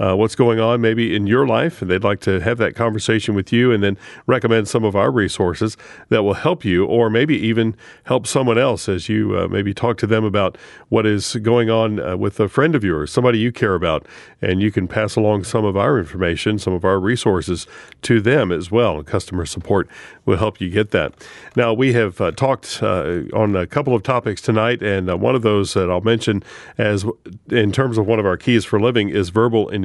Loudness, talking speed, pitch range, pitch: -18 LUFS, 230 wpm, 100-115 Hz, 110 Hz